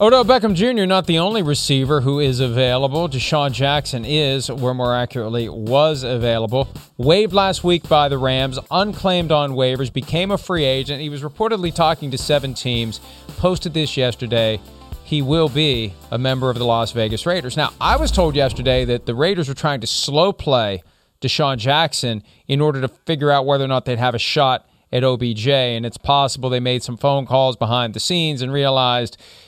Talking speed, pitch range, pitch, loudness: 190 wpm, 125-150 Hz, 135 Hz, -18 LUFS